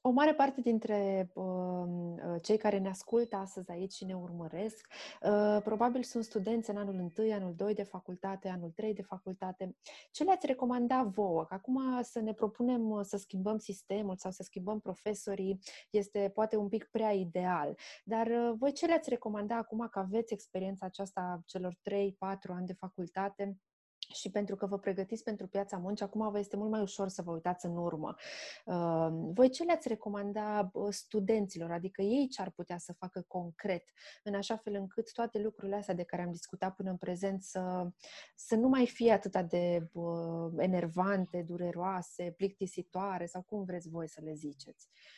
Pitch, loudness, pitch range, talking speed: 200 Hz, -36 LUFS, 185-220 Hz, 175 wpm